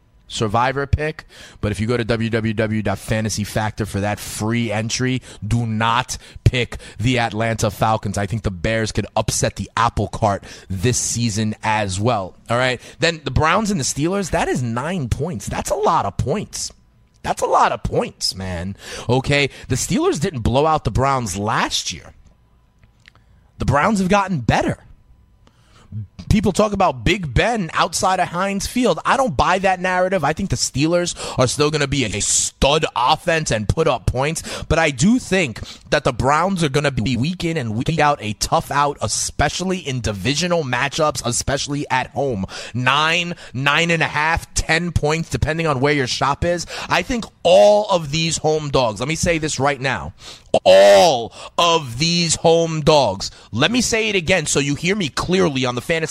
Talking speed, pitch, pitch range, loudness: 180 wpm, 135 Hz, 110-165 Hz, -19 LUFS